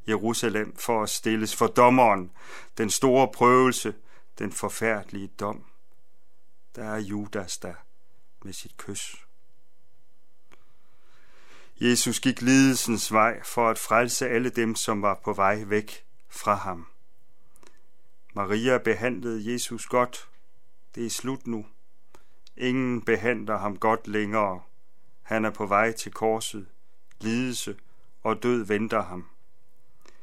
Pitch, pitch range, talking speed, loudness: 110 Hz, 105-120 Hz, 115 wpm, -25 LUFS